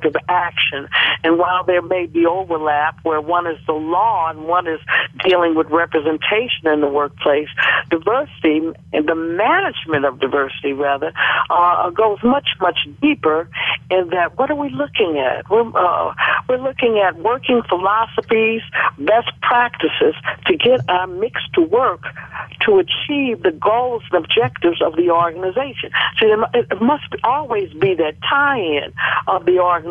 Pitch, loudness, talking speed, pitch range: 180 Hz, -17 LUFS, 150 wpm, 160-240 Hz